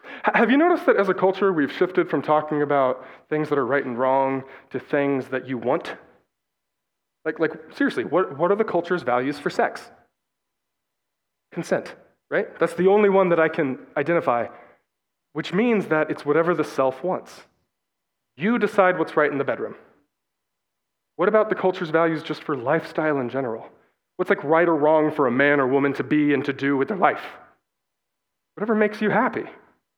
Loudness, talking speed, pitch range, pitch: -22 LUFS, 180 wpm, 140-185 Hz, 155 Hz